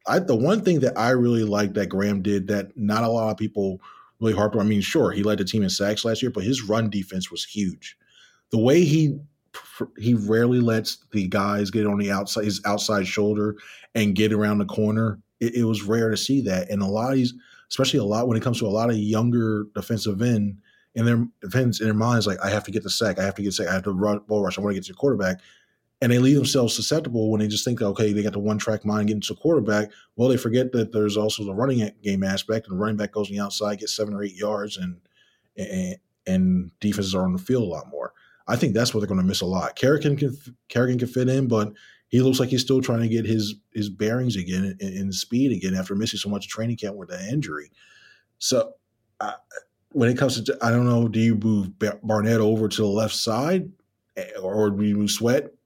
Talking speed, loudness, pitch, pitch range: 250 wpm, -23 LUFS, 110 Hz, 105-120 Hz